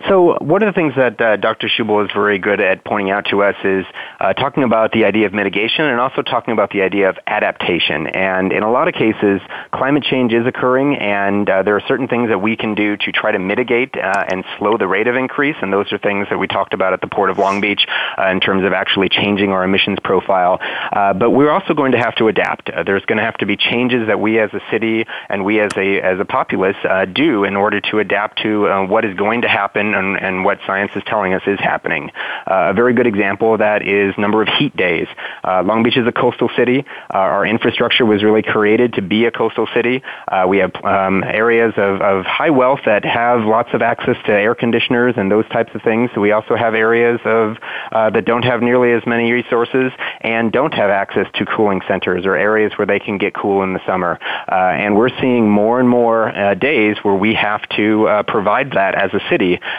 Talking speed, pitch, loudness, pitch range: 240 wpm, 110 Hz, -15 LUFS, 100-120 Hz